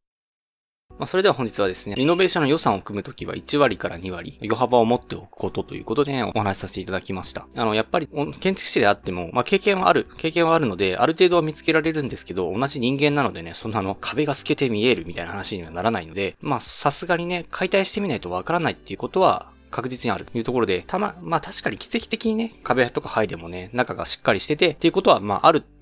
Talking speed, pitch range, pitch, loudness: 500 characters per minute, 100-165 Hz, 125 Hz, -22 LUFS